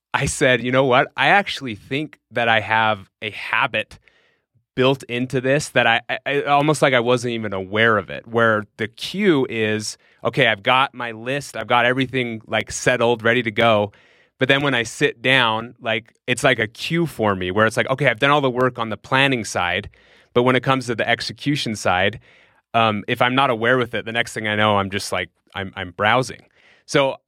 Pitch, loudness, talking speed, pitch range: 120 Hz, -19 LUFS, 215 wpm, 110-130 Hz